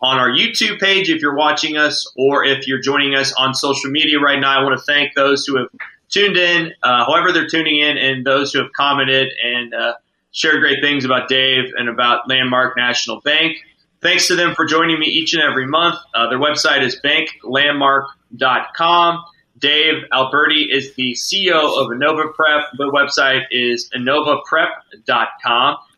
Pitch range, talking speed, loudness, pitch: 130-160 Hz, 175 wpm, -14 LUFS, 140 Hz